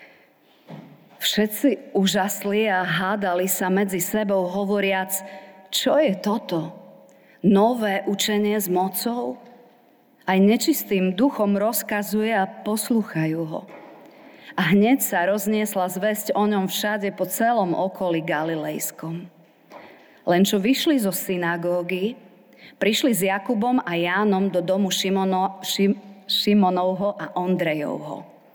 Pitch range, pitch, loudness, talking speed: 185-215 Hz, 195 Hz, -22 LUFS, 105 wpm